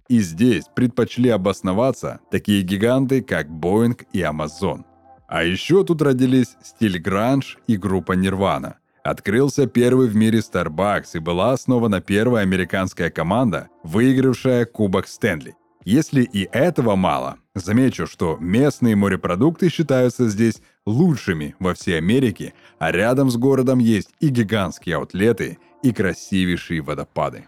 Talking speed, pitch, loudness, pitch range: 125 wpm, 110 Hz, -19 LUFS, 95-130 Hz